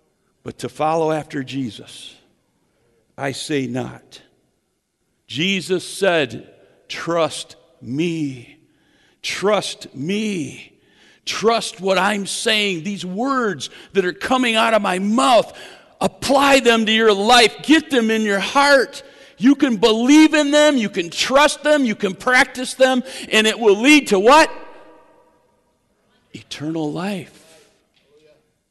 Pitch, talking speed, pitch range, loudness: 205 Hz, 120 wpm, 165-255 Hz, -17 LUFS